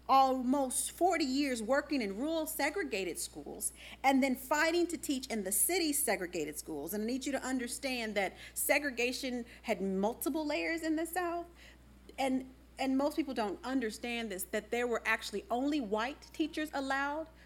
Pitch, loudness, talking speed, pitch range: 270 Hz, -34 LUFS, 160 wpm, 235-310 Hz